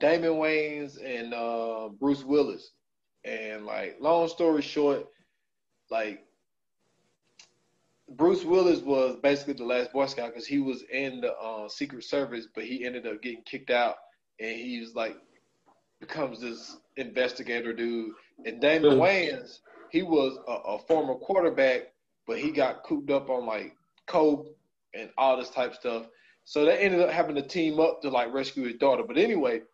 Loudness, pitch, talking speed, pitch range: -28 LUFS, 135 Hz, 165 wpm, 120-150 Hz